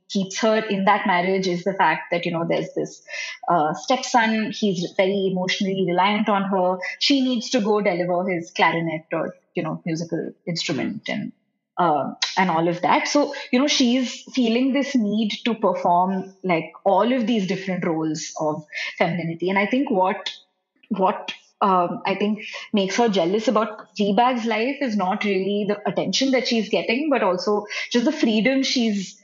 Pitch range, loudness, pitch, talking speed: 185-240 Hz, -22 LUFS, 205 Hz, 170 wpm